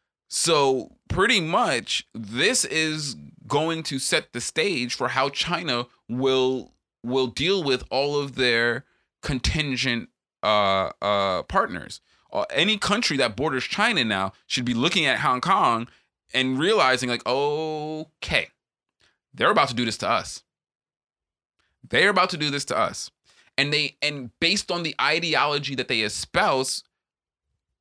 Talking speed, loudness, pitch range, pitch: 140 wpm, -23 LUFS, 120-150 Hz, 130 Hz